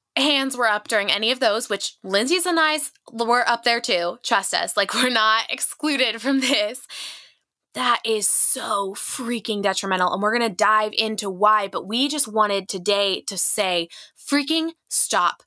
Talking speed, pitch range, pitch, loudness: 175 wpm, 205-255 Hz, 220 Hz, -21 LUFS